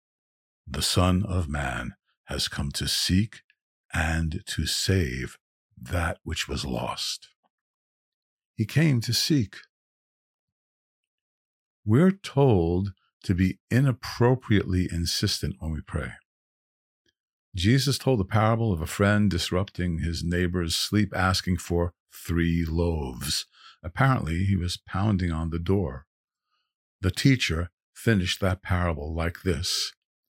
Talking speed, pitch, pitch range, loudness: 115 wpm, 90 Hz, 80-100 Hz, -26 LUFS